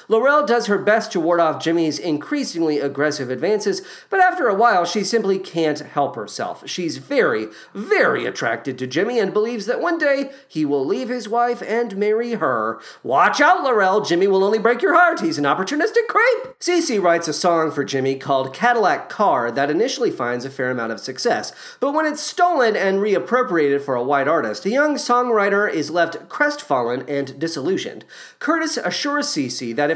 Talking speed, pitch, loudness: 185 wpm, 210 Hz, -19 LUFS